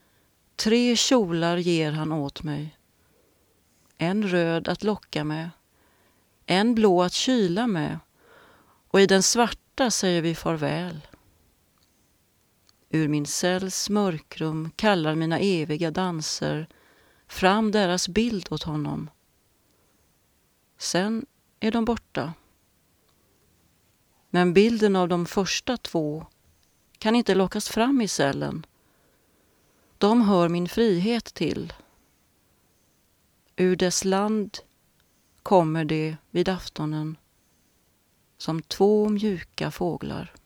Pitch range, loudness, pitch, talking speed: 150-205 Hz, -24 LUFS, 175 Hz, 100 wpm